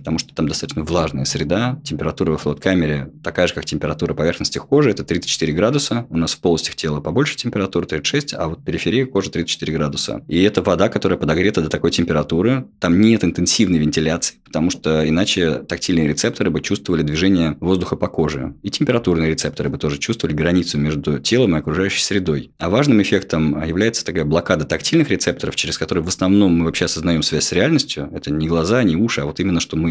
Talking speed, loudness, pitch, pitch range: 195 wpm, -18 LUFS, 80 Hz, 75-95 Hz